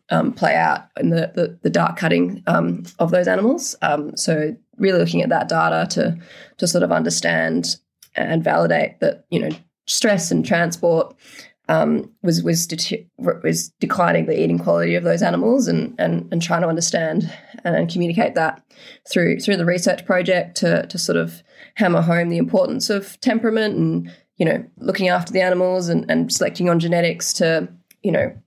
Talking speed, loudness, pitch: 175 wpm, -19 LUFS, 170 Hz